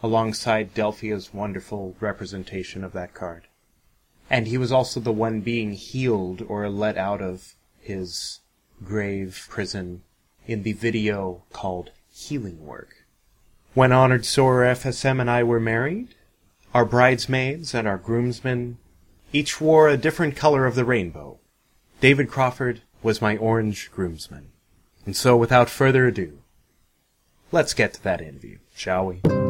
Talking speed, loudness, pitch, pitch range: 135 wpm, -22 LUFS, 115 Hz, 95-125 Hz